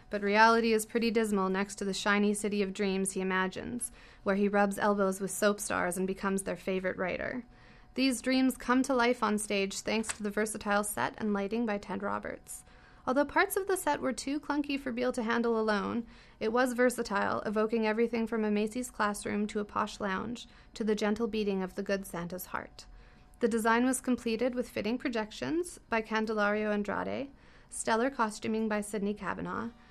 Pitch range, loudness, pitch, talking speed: 205-240 Hz, -31 LUFS, 220 Hz, 185 wpm